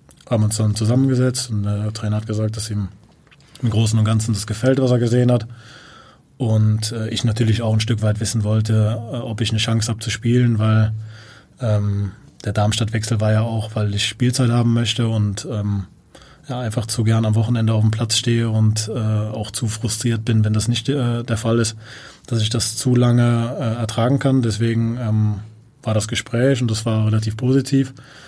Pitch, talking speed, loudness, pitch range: 115 Hz, 200 wpm, -19 LUFS, 110-120 Hz